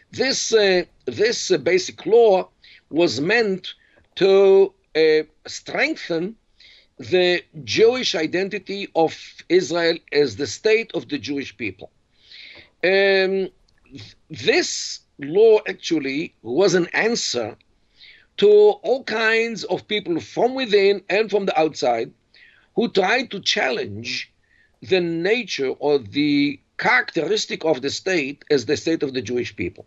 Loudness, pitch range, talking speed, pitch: -20 LUFS, 165-270 Hz, 125 wpm, 195 Hz